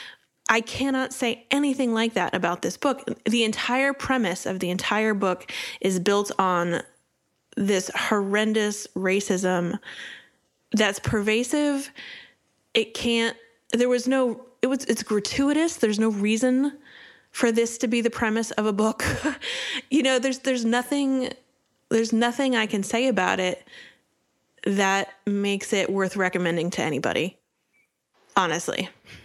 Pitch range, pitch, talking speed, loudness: 200-255 Hz, 225 Hz, 135 wpm, -24 LUFS